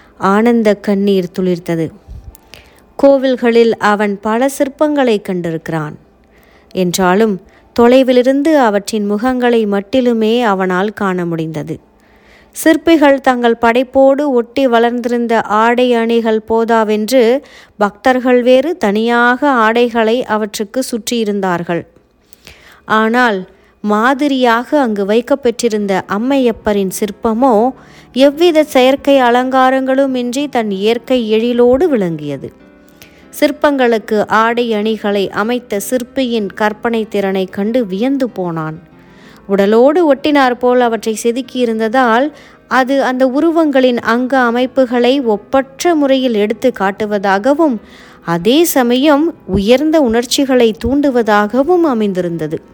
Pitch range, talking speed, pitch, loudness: 210-260 Hz, 85 wpm, 235 Hz, -12 LUFS